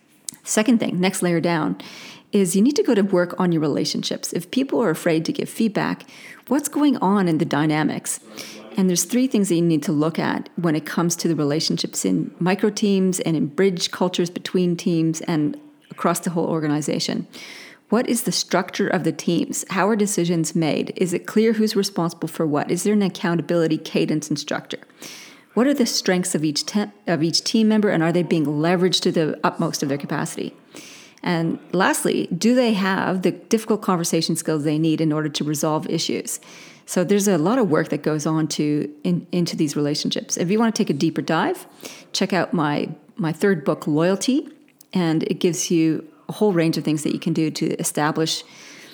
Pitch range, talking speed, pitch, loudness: 160-205 Hz, 200 wpm, 180 Hz, -21 LUFS